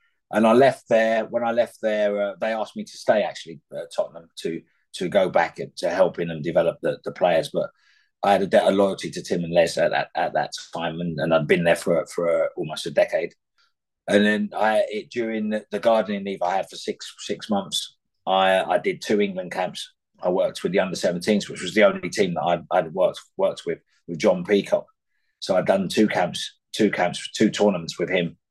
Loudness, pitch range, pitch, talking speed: -23 LUFS, 95-110 Hz, 105 Hz, 230 wpm